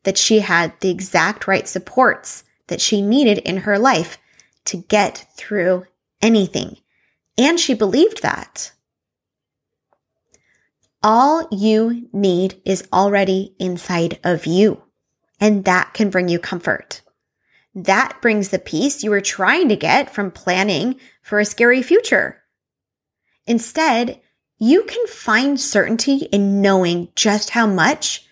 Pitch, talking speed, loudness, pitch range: 205 Hz, 125 wpm, -17 LUFS, 190-240 Hz